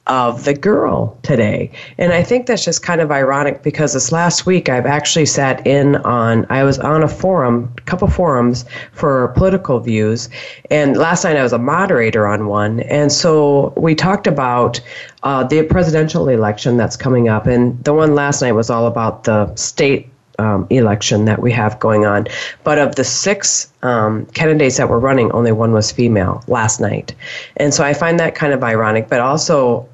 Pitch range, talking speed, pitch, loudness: 115-155 Hz, 190 wpm, 130 Hz, -14 LUFS